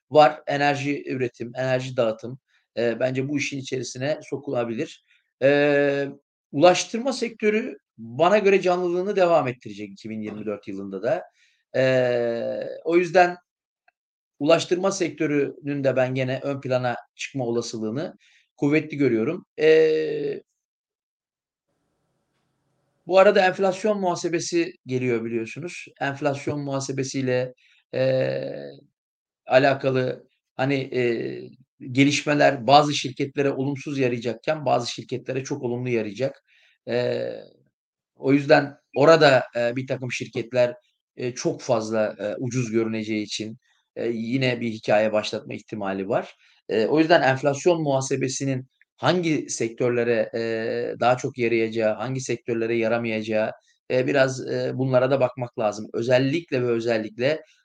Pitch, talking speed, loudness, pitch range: 130 Hz, 110 wpm, -23 LUFS, 120-150 Hz